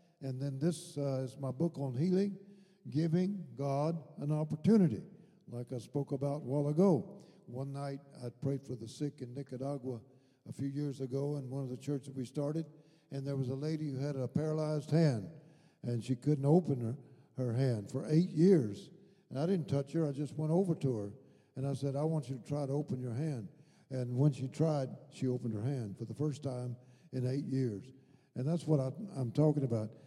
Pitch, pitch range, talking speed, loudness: 140 Hz, 130-155 Hz, 210 wpm, -35 LUFS